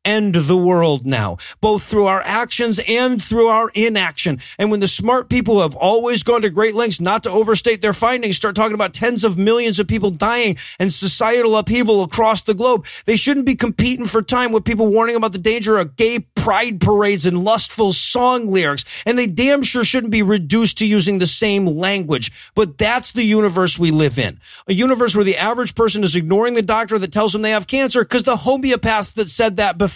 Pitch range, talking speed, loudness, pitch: 195-230 Hz, 210 wpm, -16 LUFS, 215 Hz